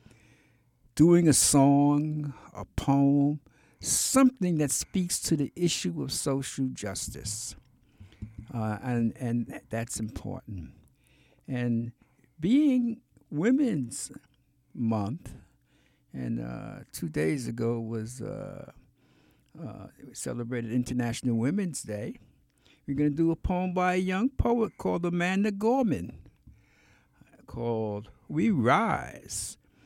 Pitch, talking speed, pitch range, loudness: 125 Hz, 105 wpm, 110-160 Hz, -28 LUFS